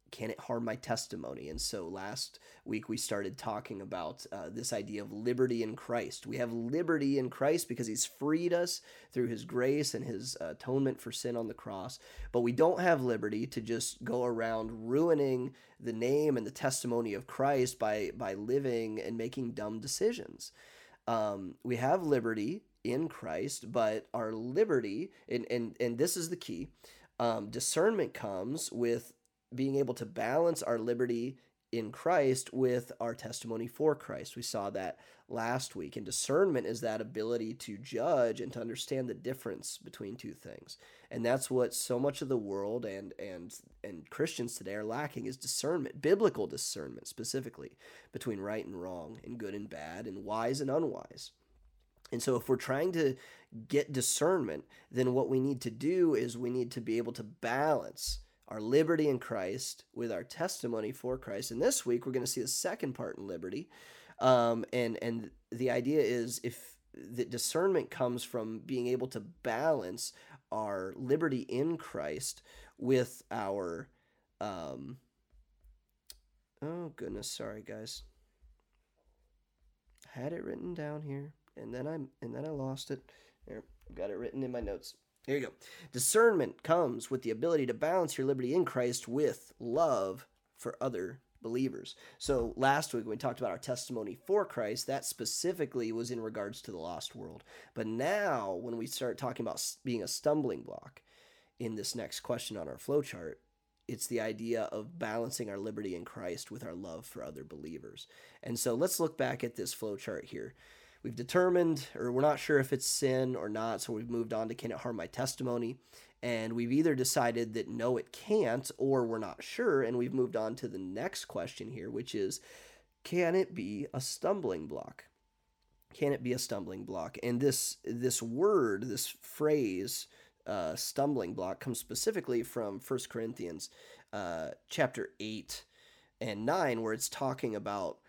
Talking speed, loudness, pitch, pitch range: 175 wpm, -35 LUFS, 125 Hz, 115-135 Hz